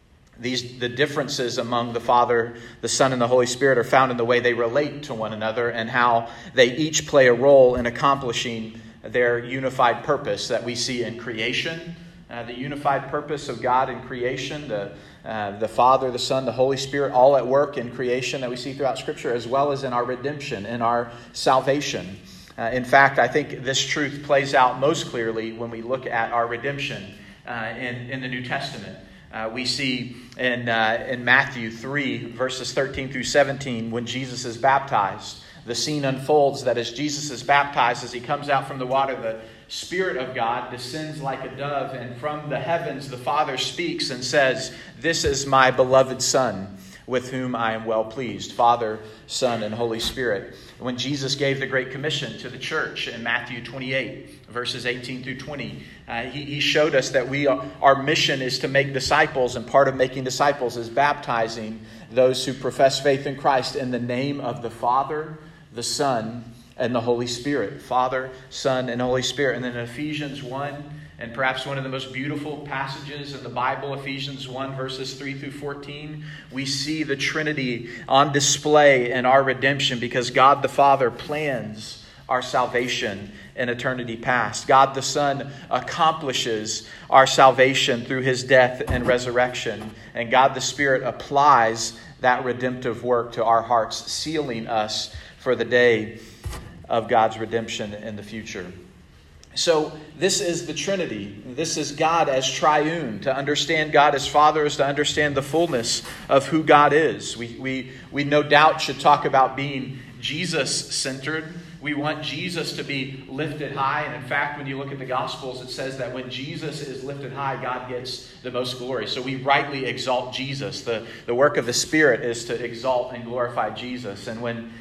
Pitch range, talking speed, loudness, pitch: 120-140 Hz, 180 wpm, -22 LUFS, 130 Hz